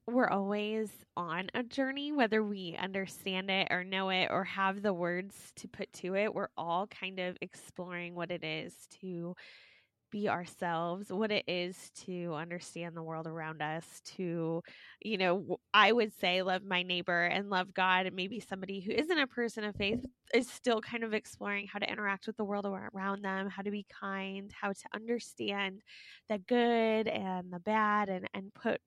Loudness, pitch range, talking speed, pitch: -34 LUFS, 180-210 Hz, 185 wpm, 195 Hz